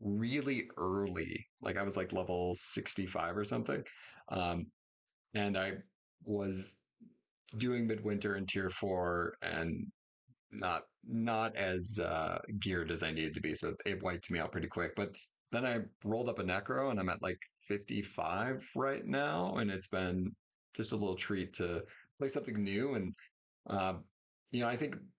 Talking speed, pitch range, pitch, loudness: 160 wpm, 90-110 Hz, 95 Hz, -38 LUFS